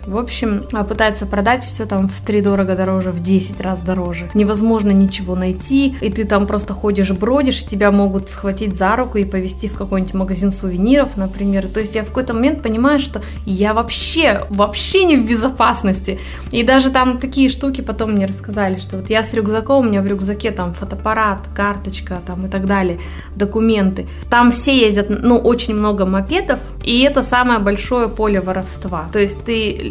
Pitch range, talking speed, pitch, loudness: 195-235 Hz, 185 wpm, 210 Hz, -16 LUFS